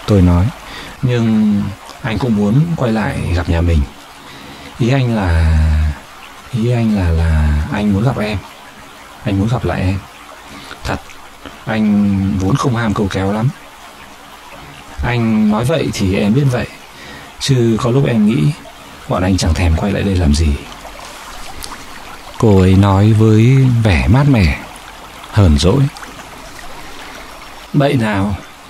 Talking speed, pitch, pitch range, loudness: 140 wpm, 95 Hz, 70-110 Hz, -14 LUFS